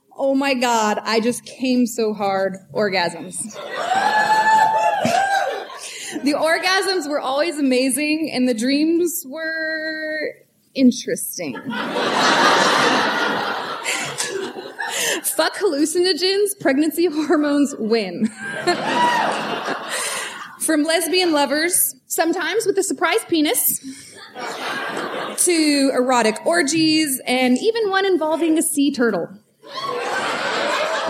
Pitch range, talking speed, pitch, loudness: 255-360 Hz, 80 wpm, 310 Hz, -19 LUFS